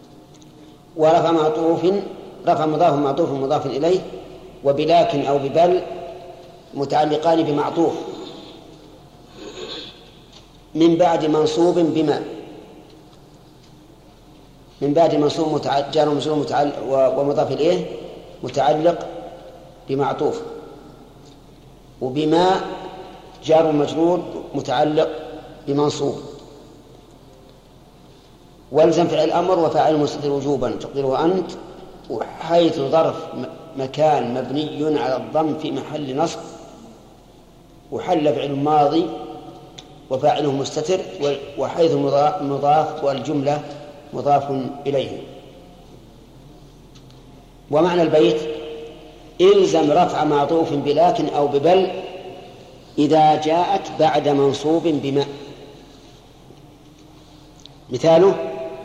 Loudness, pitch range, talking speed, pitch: -19 LUFS, 145-165 Hz, 70 wpm, 150 Hz